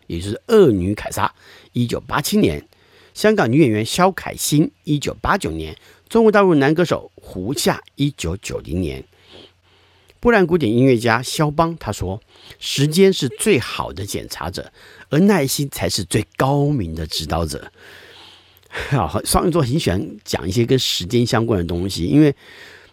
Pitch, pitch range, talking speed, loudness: 125 Hz, 100-160 Hz, 240 characters per minute, -18 LUFS